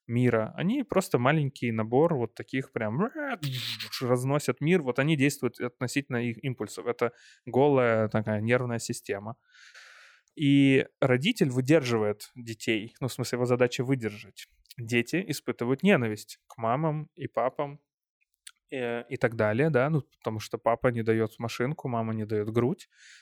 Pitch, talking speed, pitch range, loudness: 125 Hz, 140 wpm, 115-140 Hz, -28 LUFS